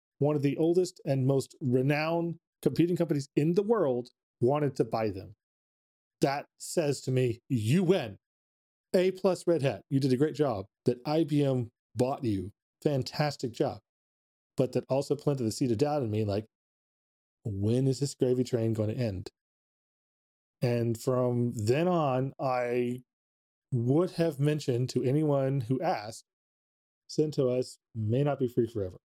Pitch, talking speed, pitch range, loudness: 130 Hz, 155 wpm, 115-150 Hz, -30 LUFS